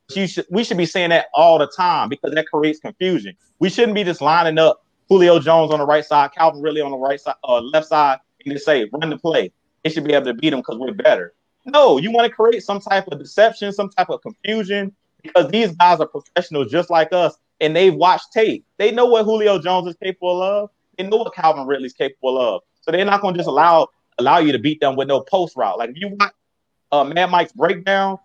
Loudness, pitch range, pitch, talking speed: -17 LUFS, 155-200 Hz, 175 Hz, 245 wpm